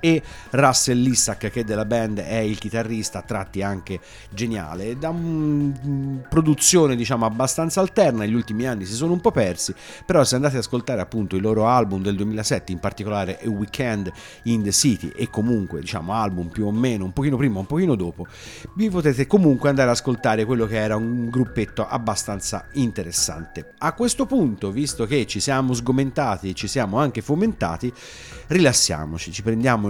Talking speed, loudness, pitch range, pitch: 175 wpm, -21 LUFS, 105-135 Hz, 115 Hz